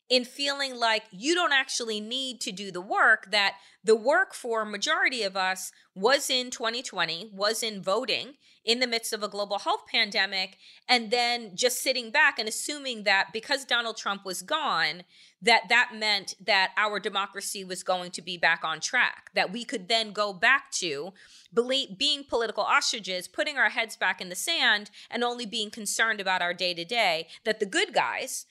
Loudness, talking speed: -26 LUFS, 185 wpm